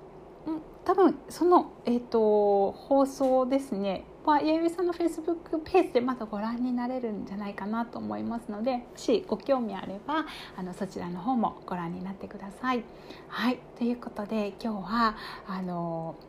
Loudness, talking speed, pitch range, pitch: -29 LUFS, 335 characters per minute, 200-275 Hz, 235 Hz